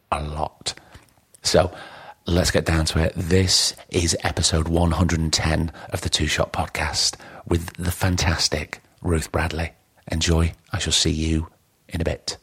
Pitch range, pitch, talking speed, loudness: 80-90 Hz, 85 Hz, 145 wpm, -22 LUFS